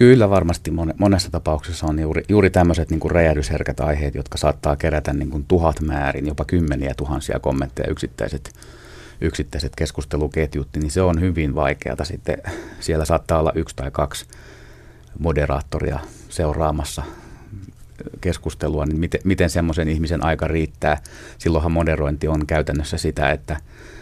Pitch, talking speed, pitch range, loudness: 80 Hz, 130 wpm, 75-85 Hz, -21 LUFS